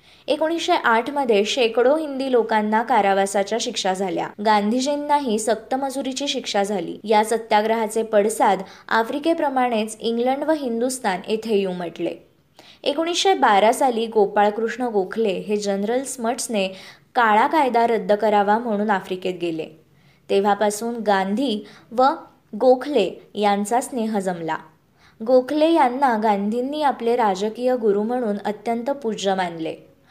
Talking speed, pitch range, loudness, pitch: 105 wpm, 205-255 Hz, -21 LUFS, 225 Hz